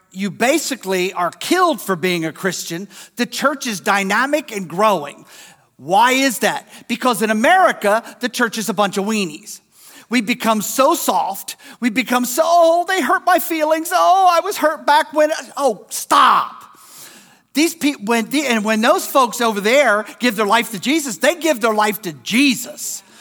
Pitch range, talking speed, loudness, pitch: 210-300 Hz, 175 wpm, -17 LUFS, 245 Hz